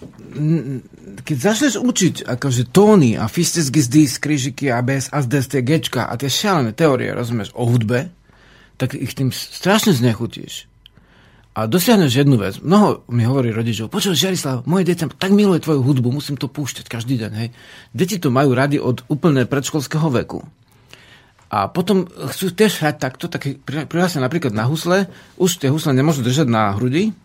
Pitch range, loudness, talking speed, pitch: 125-170 Hz, -18 LUFS, 160 wpm, 140 Hz